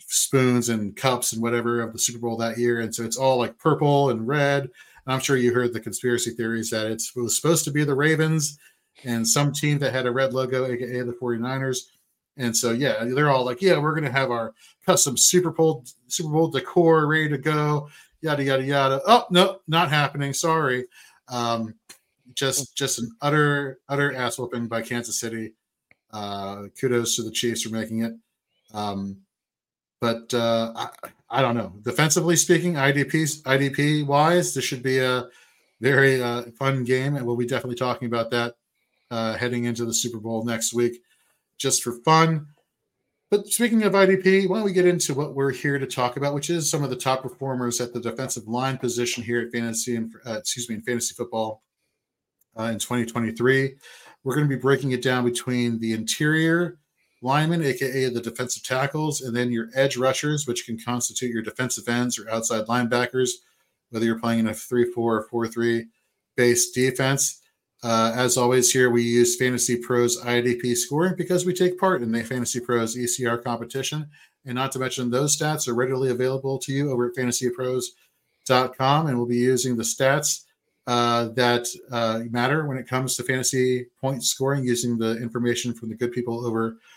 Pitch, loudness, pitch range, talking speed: 125 Hz, -23 LUFS, 120-140 Hz, 190 wpm